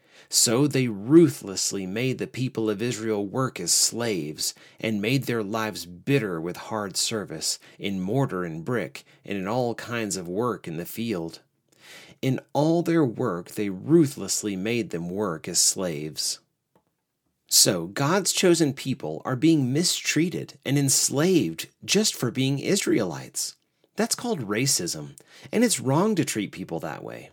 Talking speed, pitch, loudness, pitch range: 145 wpm, 130 Hz, -24 LUFS, 105-155 Hz